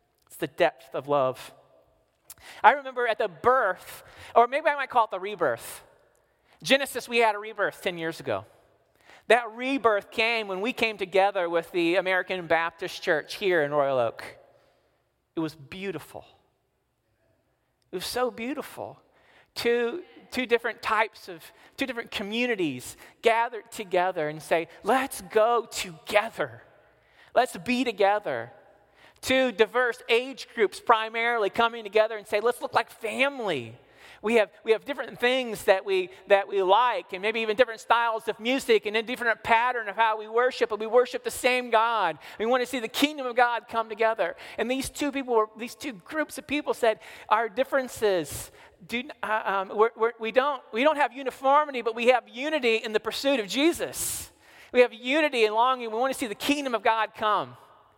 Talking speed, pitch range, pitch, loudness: 175 wpm, 210-255 Hz, 230 Hz, -26 LUFS